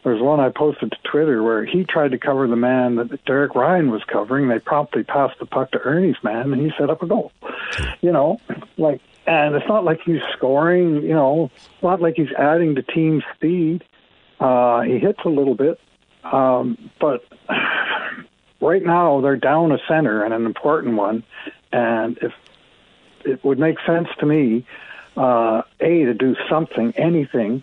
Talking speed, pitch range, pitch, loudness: 180 wpm, 125-160 Hz, 145 Hz, -19 LUFS